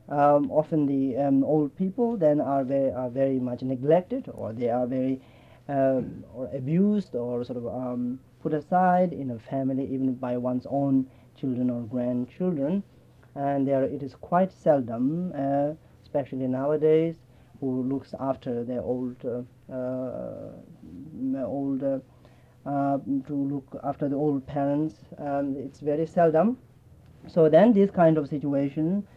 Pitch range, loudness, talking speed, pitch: 125-155 Hz, -26 LUFS, 145 wpm, 135 Hz